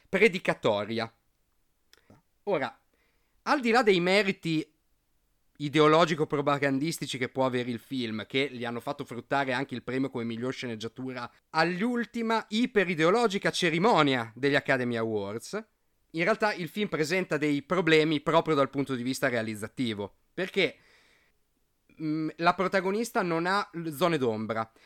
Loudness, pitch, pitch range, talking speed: -28 LUFS, 150 Hz, 125-180 Hz, 125 wpm